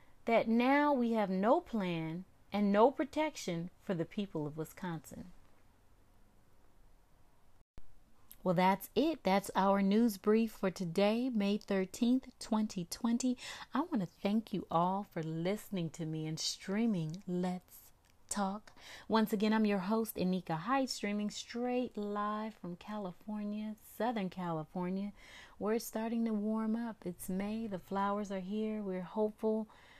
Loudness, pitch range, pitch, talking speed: -35 LUFS, 180-220 Hz, 205 Hz, 135 wpm